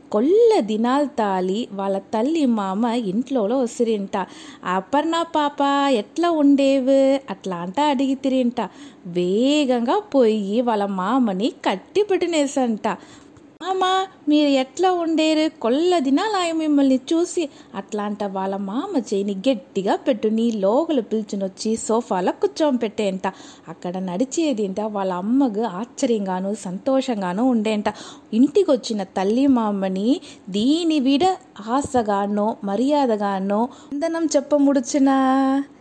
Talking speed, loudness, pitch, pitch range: 90 wpm, -21 LUFS, 255 Hz, 210-290 Hz